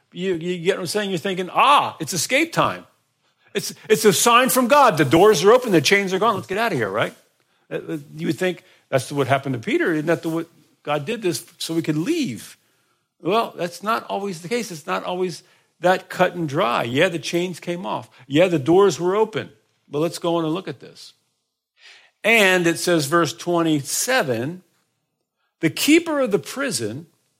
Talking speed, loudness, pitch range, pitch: 200 wpm, -20 LUFS, 155-195 Hz, 175 Hz